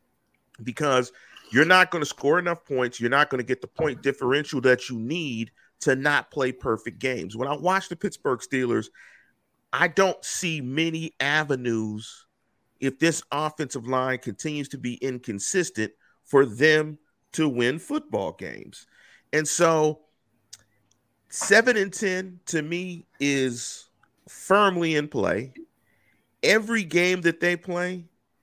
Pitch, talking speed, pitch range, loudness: 150 Hz, 135 wpm, 125-170 Hz, -24 LUFS